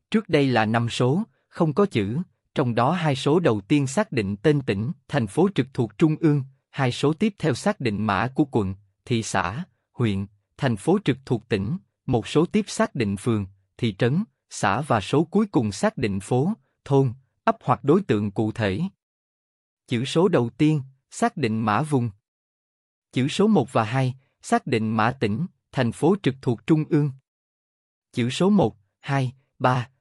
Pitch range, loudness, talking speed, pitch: 110-155 Hz, -24 LUFS, 185 wpm, 130 Hz